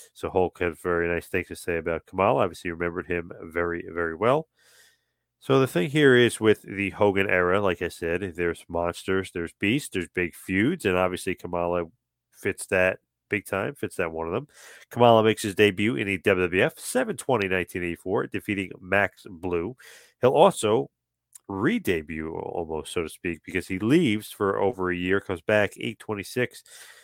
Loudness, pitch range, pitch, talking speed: -25 LUFS, 85-105 Hz, 95 Hz, 170 wpm